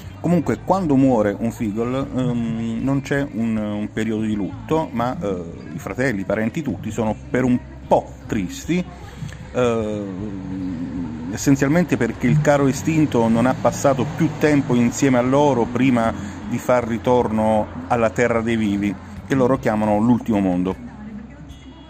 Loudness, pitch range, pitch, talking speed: -20 LUFS, 105-135 Hz, 120 Hz, 145 wpm